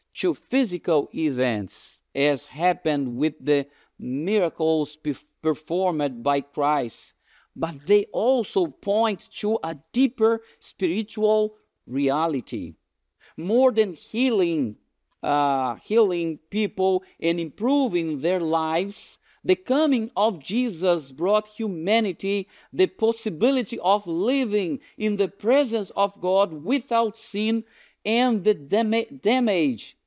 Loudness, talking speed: -24 LUFS, 100 wpm